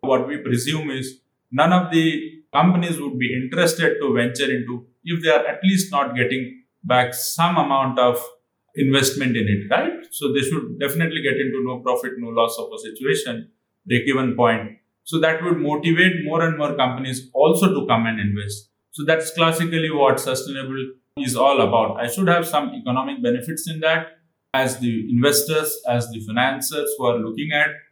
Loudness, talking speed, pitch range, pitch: -20 LUFS, 180 wpm, 125-160 Hz, 135 Hz